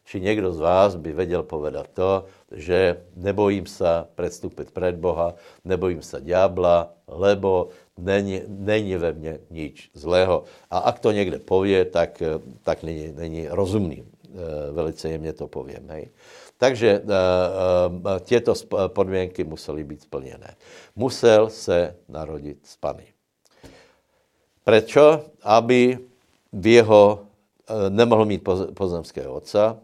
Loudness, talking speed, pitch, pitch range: -21 LUFS, 115 wpm, 95 Hz, 85-100 Hz